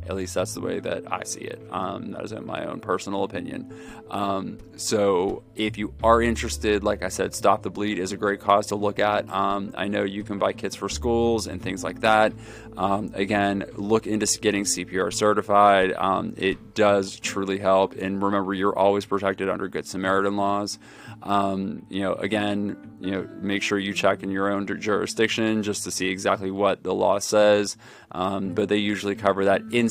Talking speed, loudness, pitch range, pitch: 200 wpm, -24 LUFS, 95-105 Hz, 100 Hz